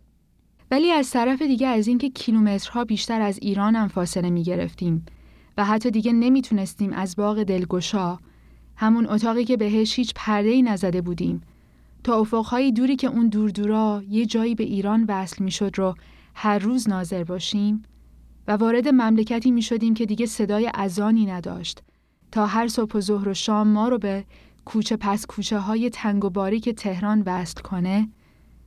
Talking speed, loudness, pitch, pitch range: 165 wpm, -22 LUFS, 215 Hz, 195-230 Hz